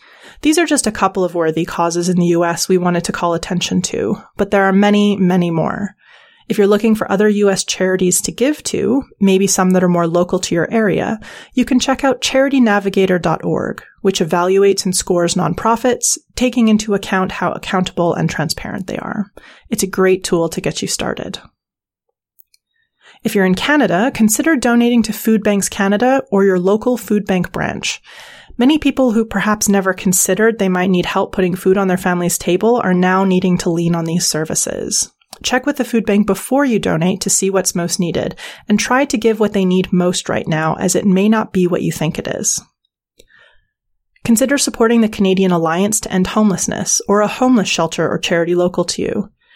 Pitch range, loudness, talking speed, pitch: 180-225 Hz, -15 LUFS, 195 wpm, 195 Hz